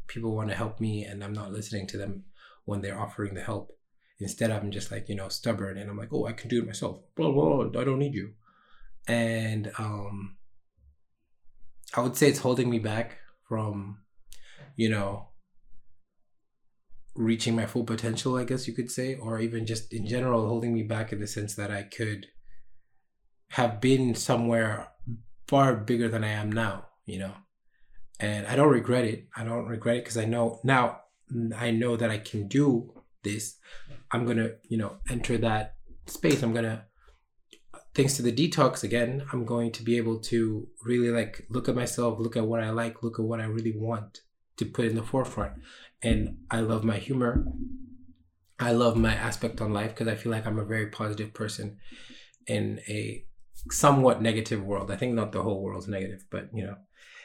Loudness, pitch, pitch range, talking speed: -29 LUFS, 115 Hz, 105-120 Hz, 190 wpm